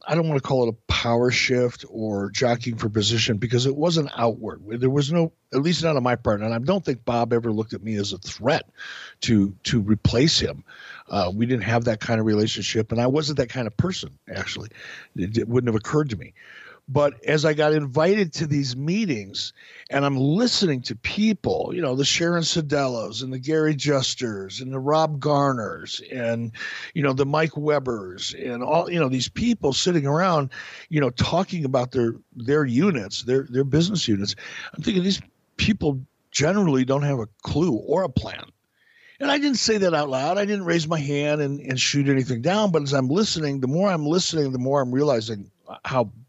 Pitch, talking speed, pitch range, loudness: 135 Hz, 205 wpm, 115-155 Hz, -23 LUFS